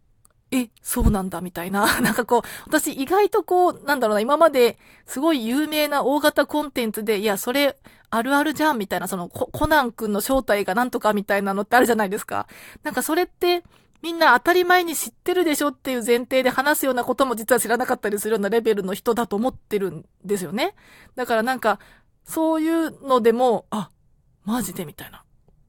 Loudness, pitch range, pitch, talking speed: -21 LUFS, 210-300 Hz, 245 Hz, 415 characters per minute